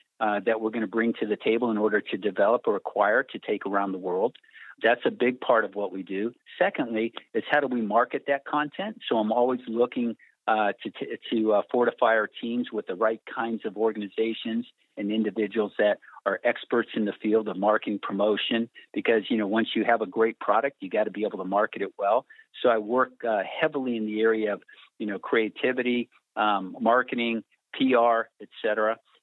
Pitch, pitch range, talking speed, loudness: 115 Hz, 110-120 Hz, 205 wpm, -26 LUFS